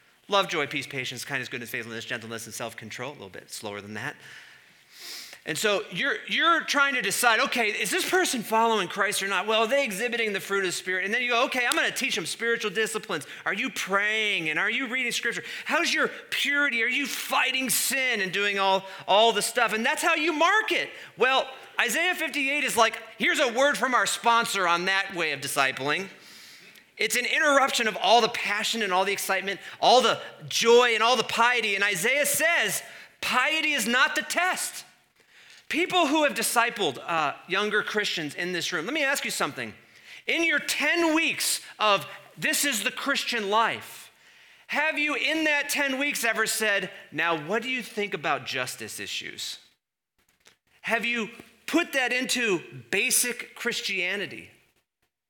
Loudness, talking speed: -24 LUFS, 180 wpm